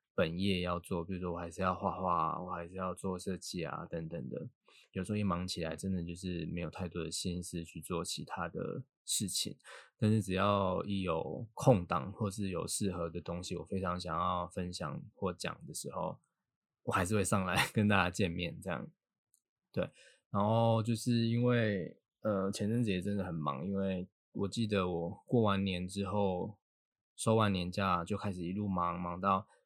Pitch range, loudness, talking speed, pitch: 90-100 Hz, -35 LUFS, 260 characters per minute, 95 Hz